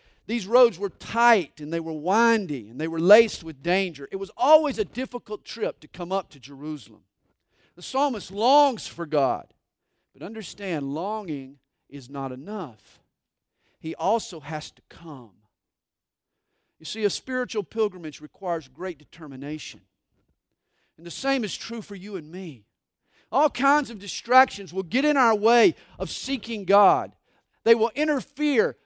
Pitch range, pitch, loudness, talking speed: 150-230 Hz, 190 Hz, -24 LUFS, 150 wpm